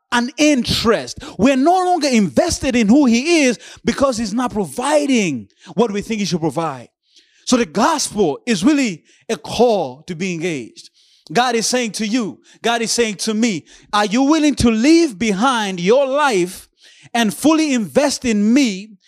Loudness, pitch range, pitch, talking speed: -17 LUFS, 210-275 Hz, 235 Hz, 165 wpm